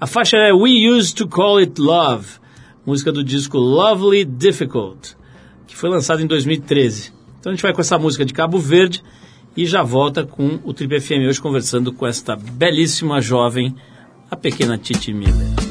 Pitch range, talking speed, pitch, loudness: 125-175 Hz, 175 wpm, 145 Hz, -16 LUFS